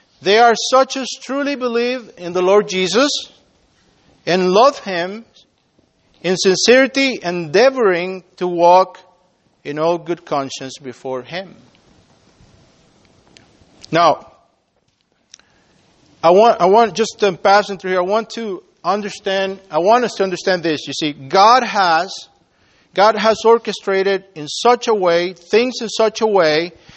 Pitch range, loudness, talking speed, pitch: 175-225 Hz, -15 LUFS, 135 wpm, 195 Hz